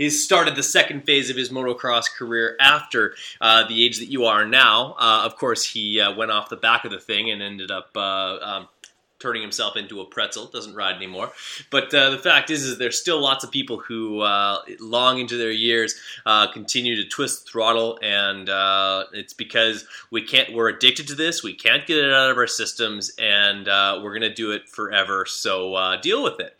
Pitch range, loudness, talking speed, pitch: 100-130 Hz, -19 LUFS, 215 wpm, 115 Hz